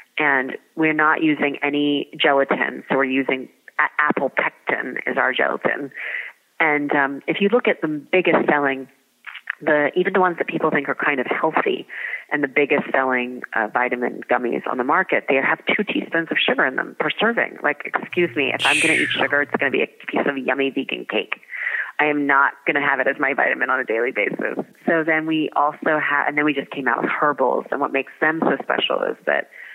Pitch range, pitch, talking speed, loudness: 135-160 Hz, 145 Hz, 220 wpm, -20 LUFS